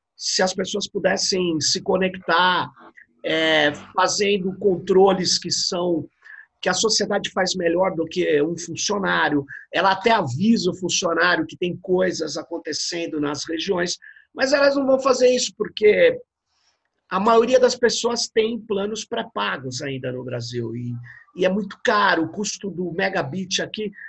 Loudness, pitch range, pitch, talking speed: -21 LUFS, 165-215 Hz, 185 Hz, 145 wpm